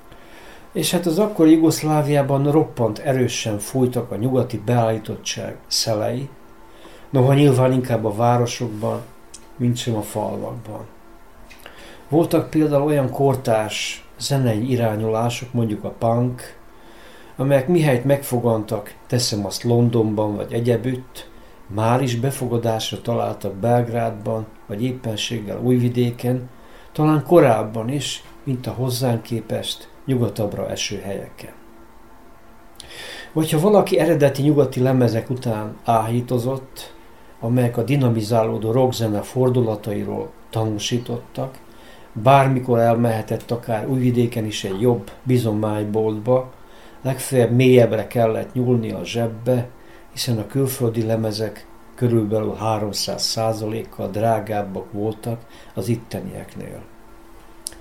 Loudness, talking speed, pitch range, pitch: -20 LUFS, 100 wpm, 110-130 Hz, 115 Hz